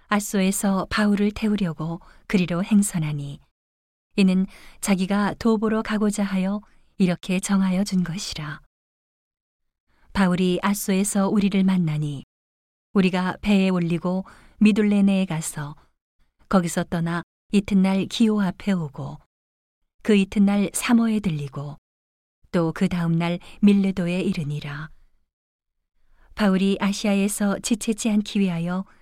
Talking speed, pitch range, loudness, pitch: 250 characters per minute, 155-200 Hz, -22 LUFS, 190 Hz